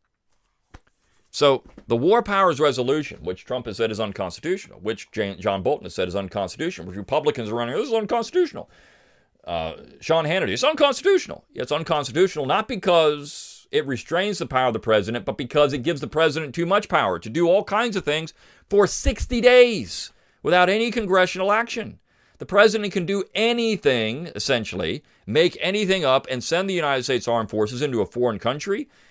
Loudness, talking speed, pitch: -22 LUFS, 175 wpm, 170 Hz